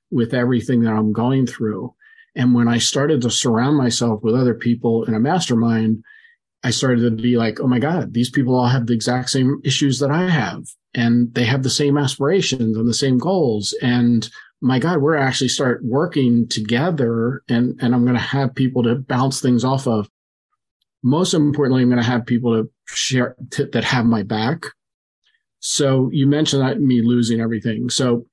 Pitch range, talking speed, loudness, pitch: 120-140 Hz, 190 wpm, -18 LUFS, 125 Hz